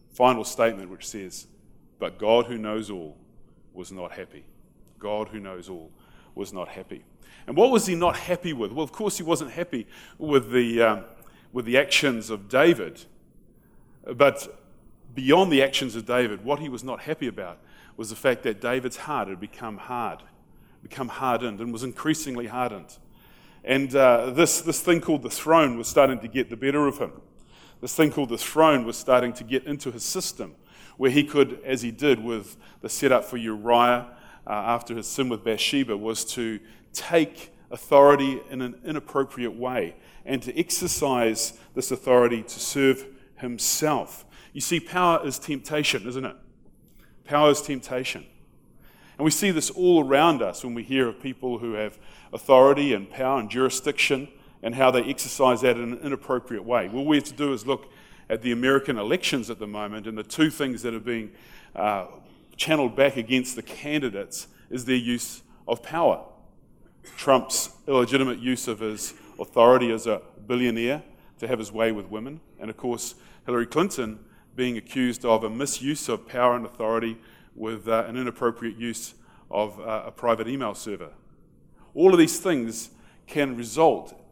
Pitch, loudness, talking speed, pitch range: 125 Hz, -24 LUFS, 175 wpm, 115-140 Hz